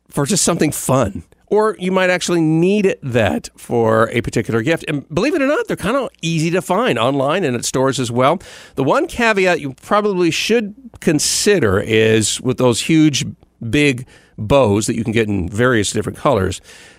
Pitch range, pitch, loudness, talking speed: 115-185 Hz, 140 Hz, -16 LUFS, 185 wpm